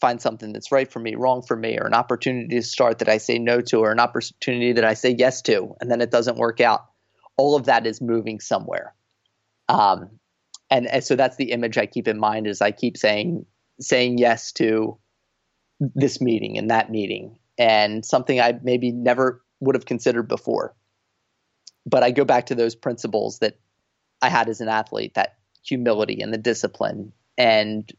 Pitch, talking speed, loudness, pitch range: 120 Hz, 195 wpm, -21 LUFS, 110-125 Hz